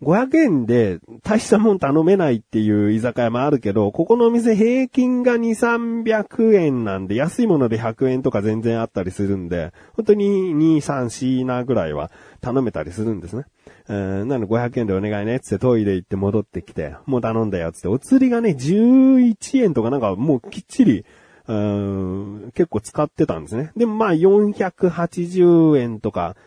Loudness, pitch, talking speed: -19 LUFS, 130 Hz, 315 characters per minute